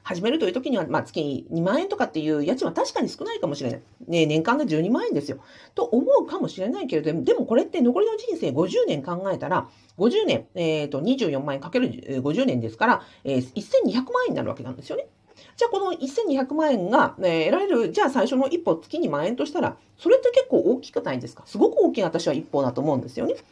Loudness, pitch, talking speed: -24 LUFS, 270 Hz, 405 characters per minute